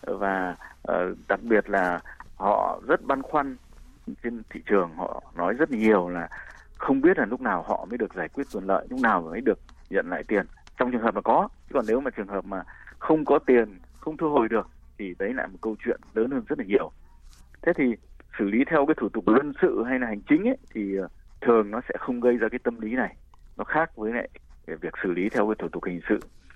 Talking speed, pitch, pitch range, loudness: 235 wpm, 110 Hz, 90-125 Hz, -26 LUFS